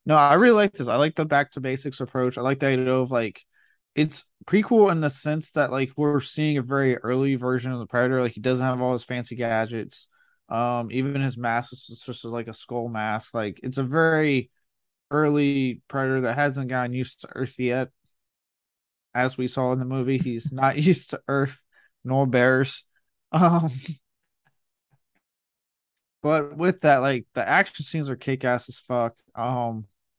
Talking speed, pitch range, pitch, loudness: 185 wpm, 125-145 Hz, 130 Hz, -24 LUFS